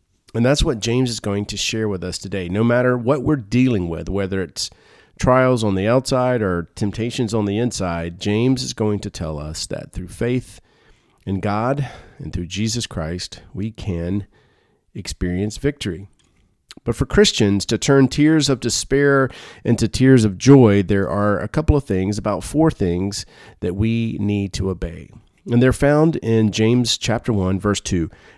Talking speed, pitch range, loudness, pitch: 175 wpm, 95-125 Hz, -19 LUFS, 105 Hz